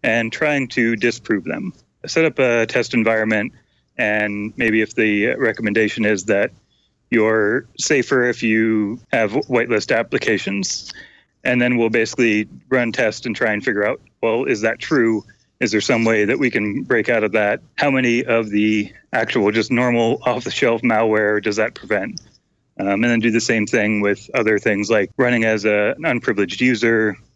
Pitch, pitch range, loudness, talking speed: 110 Hz, 105-120 Hz, -18 LUFS, 180 wpm